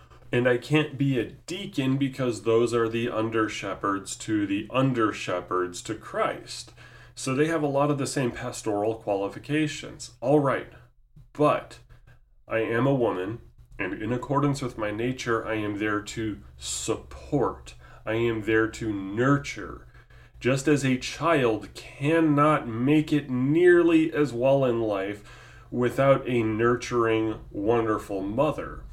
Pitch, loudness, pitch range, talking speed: 120 Hz, -26 LUFS, 110-135 Hz, 140 wpm